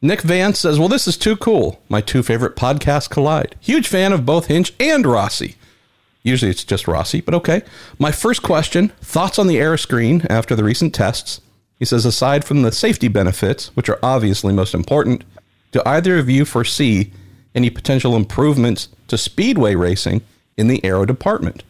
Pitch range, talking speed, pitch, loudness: 110-155 Hz, 180 wpm, 125 Hz, -16 LUFS